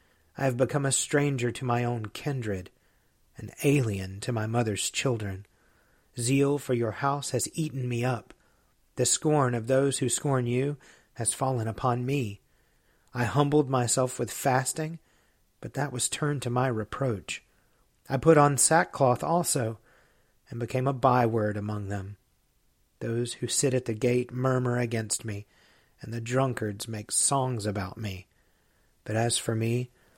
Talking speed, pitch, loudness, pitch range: 155 wpm, 125 Hz, -28 LUFS, 110-135 Hz